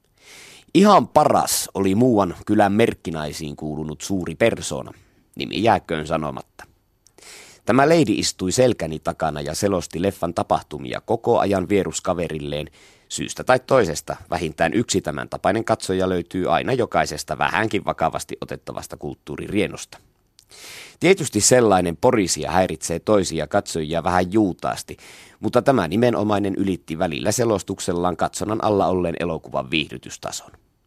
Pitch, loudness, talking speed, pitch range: 90 Hz, -21 LUFS, 115 wpm, 80-100 Hz